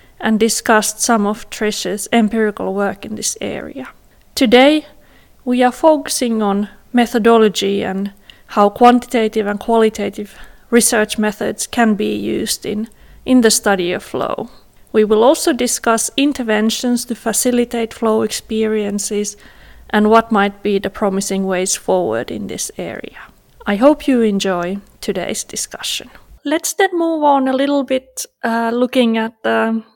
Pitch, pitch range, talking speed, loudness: 225 Hz, 205-245 Hz, 140 wpm, -16 LUFS